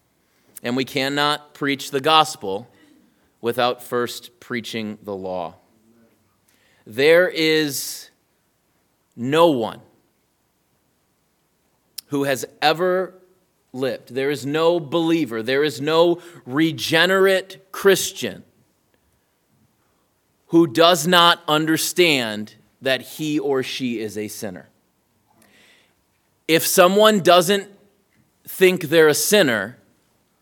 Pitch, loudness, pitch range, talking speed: 150 Hz, -19 LUFS, 120-170 Hz, 90 wpm